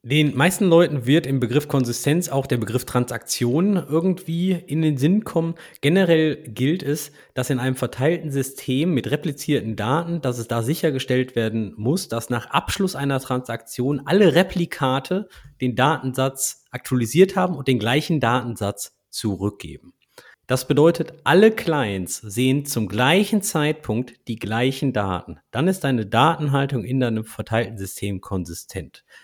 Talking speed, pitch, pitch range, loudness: 140 wpm, 135 Hz, 120-160 Hz, -21 LUFS